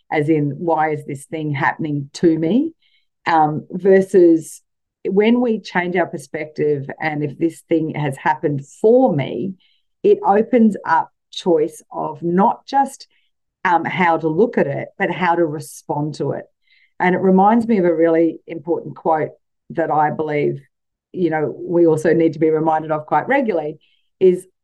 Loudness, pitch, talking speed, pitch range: -18 LUFS, 165 Hz, 165 wpm, 155-190 Hz